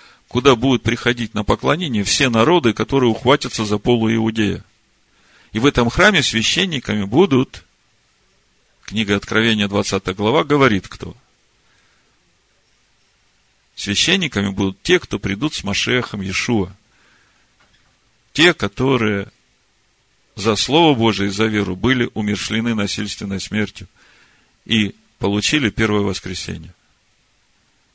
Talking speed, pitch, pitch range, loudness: 105 wpm, 110 Hz, 100-120 Hz, -17 LUFS